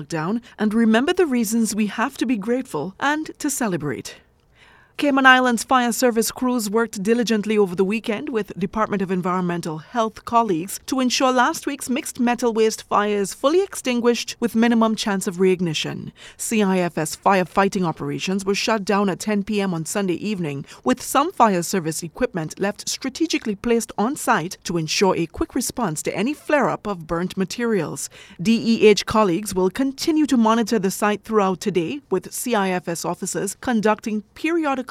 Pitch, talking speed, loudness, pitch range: 215 Hz, 160 wpm, -21 LUFS, 190-245 Hz